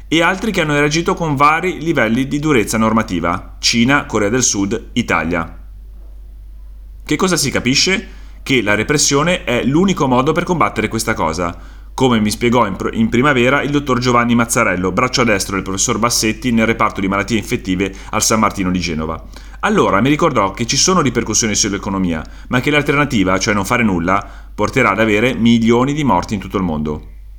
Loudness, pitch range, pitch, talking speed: -15 LUFS, 95-135 Hz, 115 Hz, 175 wpm